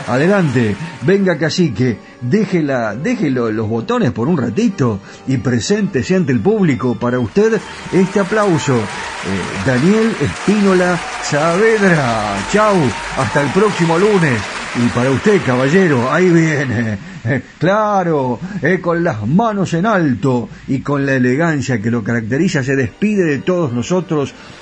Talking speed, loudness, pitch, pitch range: 130 wpm, -15 LUFS, 155 Hz, 125-190 Hz